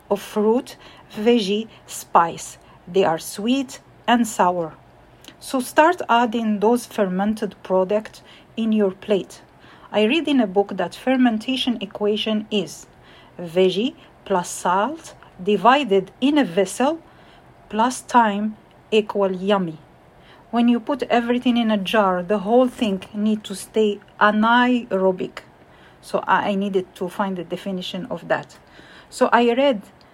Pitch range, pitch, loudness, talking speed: 195-240 Hz, 215 Hz, -20 LUFS, 125 wpm